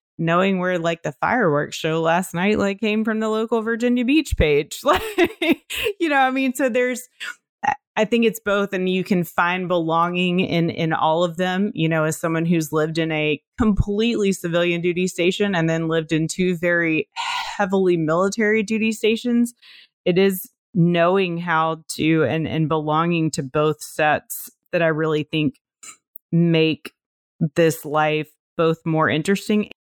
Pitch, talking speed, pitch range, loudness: 180 Hz, 160 wpm, 160-220 Hz, -20 LUFS